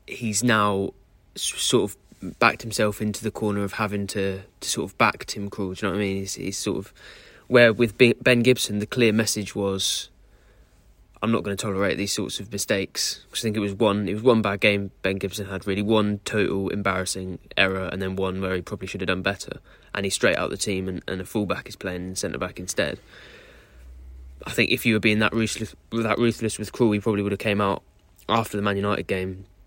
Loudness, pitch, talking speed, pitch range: -24 LUFS, 100 Hz, 225 wpm, 95-110 Hz